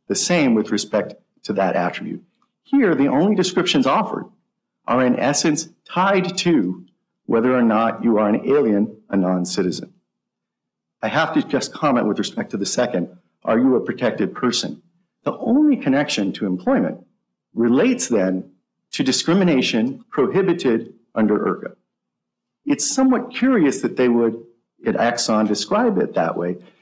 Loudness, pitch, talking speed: -19 LUFS, 130 Hz, 150 wpm